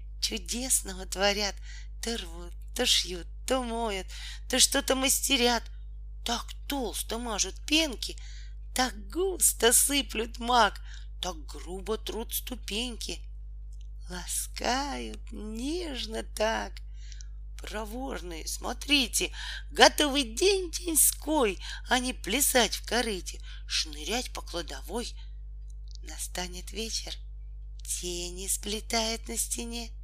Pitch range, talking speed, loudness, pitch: 170-250 Hz, 90 wpm, -28 LUFS, 220 Hz